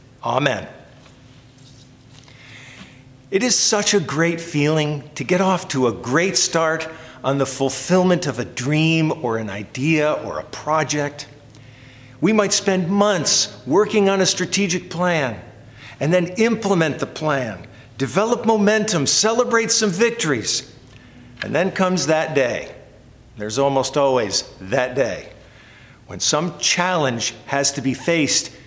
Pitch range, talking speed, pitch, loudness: 130-180 Hz, 130 wpm, 145 Hz, -19 LUFS